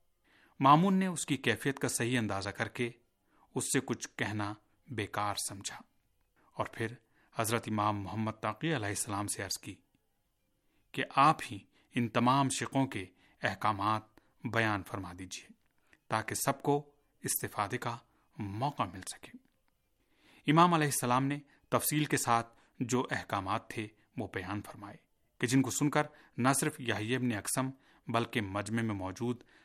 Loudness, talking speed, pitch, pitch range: -33 LUFS, 145 wpm, 120 Hz, 105-140 Hz